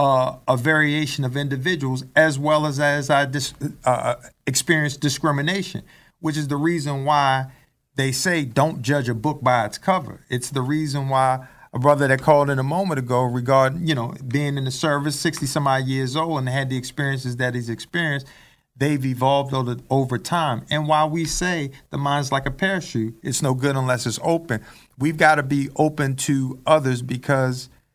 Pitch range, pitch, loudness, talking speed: 130-155 Hz, 140 Hz, -21 LUFS, 190 wpm